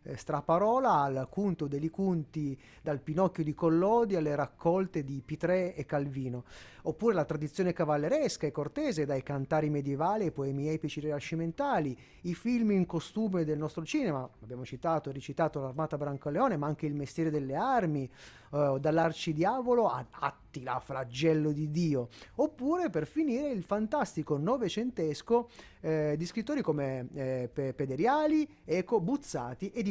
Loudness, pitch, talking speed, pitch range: -32 LUFS, 155 Hz, 145 wpm, 145-190 Hz